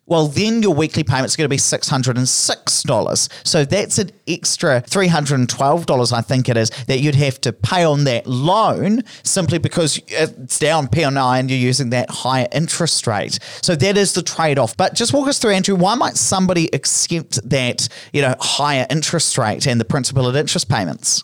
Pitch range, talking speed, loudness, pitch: 130-170 Hz, 190 wpm, -16 LUFS, 145 Hz